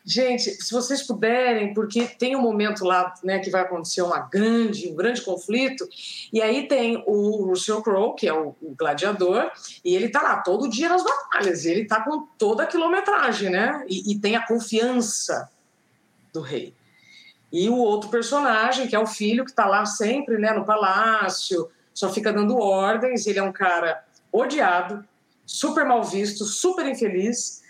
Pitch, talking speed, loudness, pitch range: 220 Hz, 175 wpm, -23 LUFS, 195-245 Hz